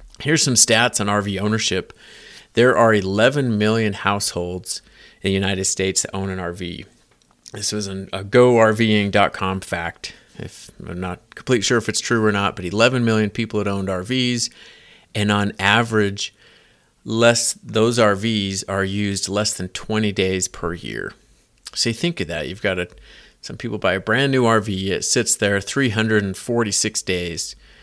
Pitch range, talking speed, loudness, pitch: 95-115 Hz, 165 wpm, -19 LUFS, 105 Hz